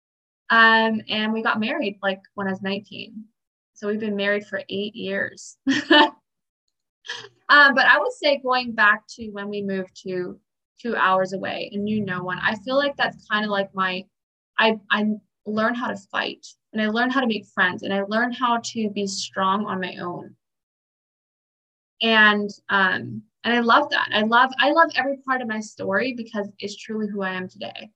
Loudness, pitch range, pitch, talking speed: -21 LUFS, 195-235 Hz, 215 Hz, 190 wpm